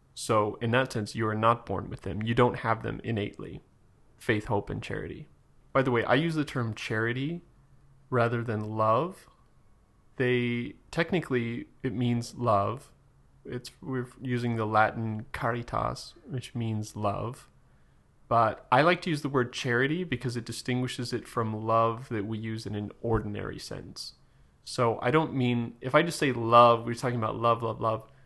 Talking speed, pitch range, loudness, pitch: 170 wpm, 110-130 Hz, -29 LUFS, 120 Hz